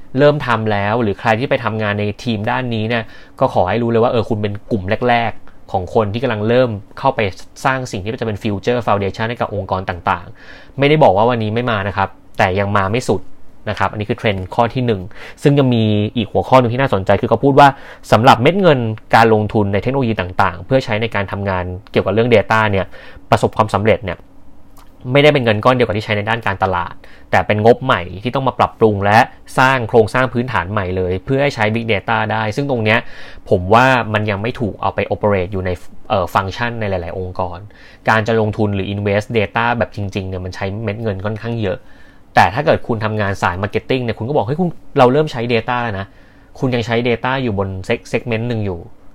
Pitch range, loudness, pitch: 100-120 Hz, -16 LUFS, 110 Hz